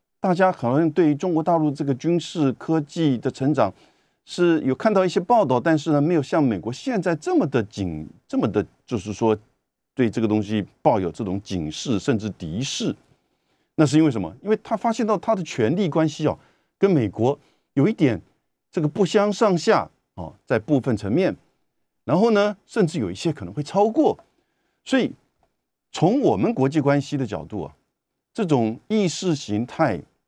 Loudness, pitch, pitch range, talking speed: -22 LUFS, 155 Hz, 120-185 Hz, 265 characters per minute